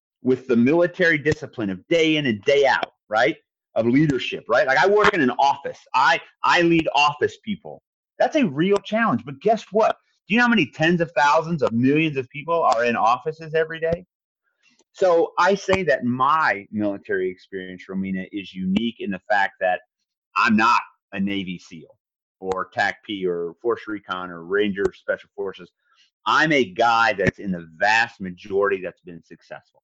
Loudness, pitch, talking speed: -21 LUFS, 145 Hz, 180 wpm